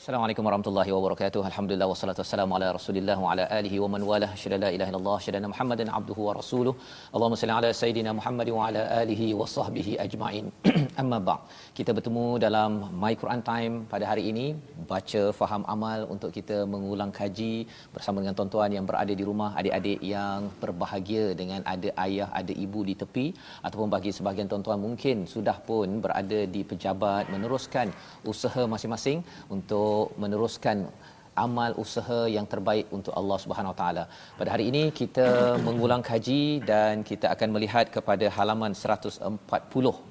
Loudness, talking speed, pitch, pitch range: -28 LUFS, 160 wpm, 105 Hz, 100-115 Hz